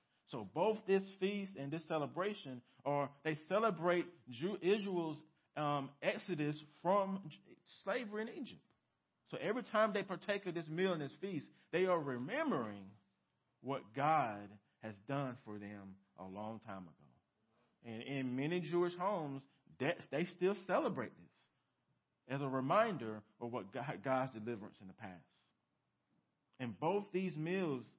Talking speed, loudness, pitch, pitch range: 140 wpm, -40 LUFS, 150 Hz, 125-185 Hz